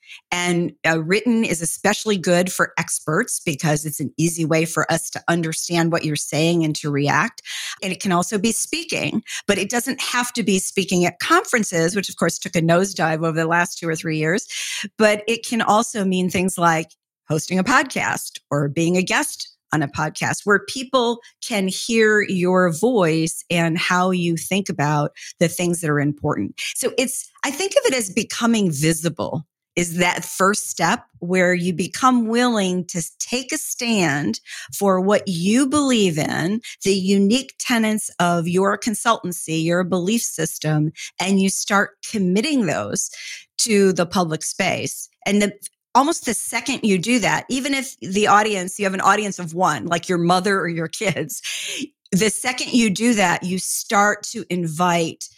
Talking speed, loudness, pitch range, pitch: 175 wpm, -20 LUFS, 170-220 Hz, 185 Hz